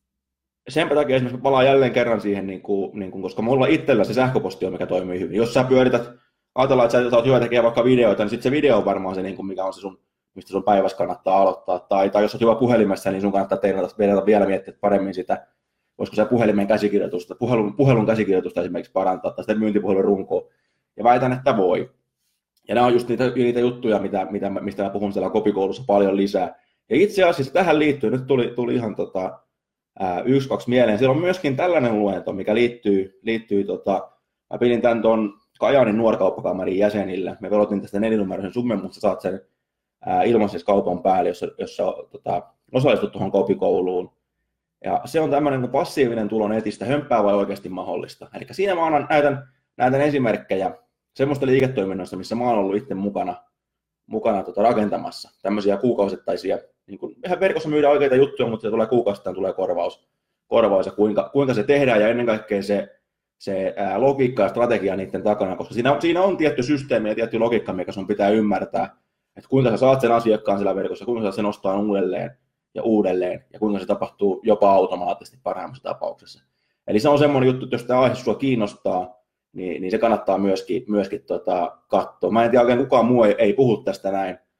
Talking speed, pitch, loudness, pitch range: 190 wpm, 110 Hz, -21 LUFS, 100-130 Hz